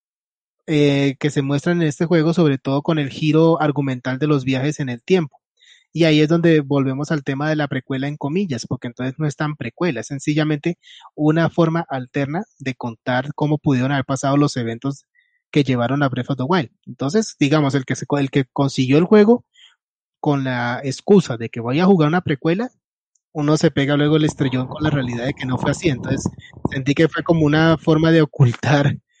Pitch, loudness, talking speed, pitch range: 150 Hz, -19 LUFS, 205 wpm, 135-165 Hz